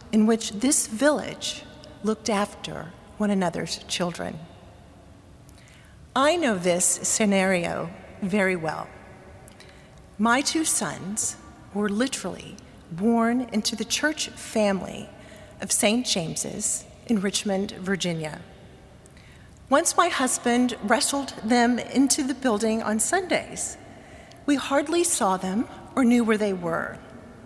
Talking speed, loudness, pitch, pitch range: 110 wpm, -24 LUFS, 225 Hz, 205-260 Hz